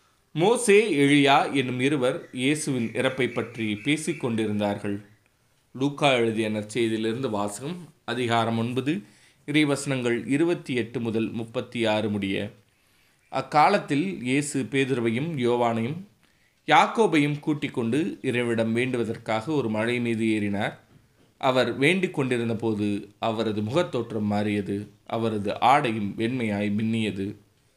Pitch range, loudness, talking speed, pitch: 110-135 Hz, -25 LUFS, 100 wpm, 120 Hz